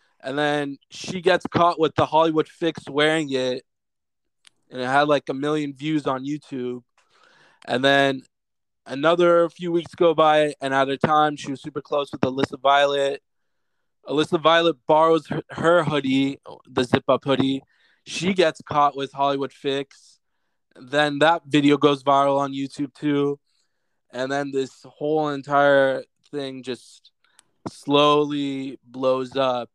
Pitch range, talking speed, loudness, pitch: 135-155 Hz, 145 wpm, -21 LUFS, 140 Hz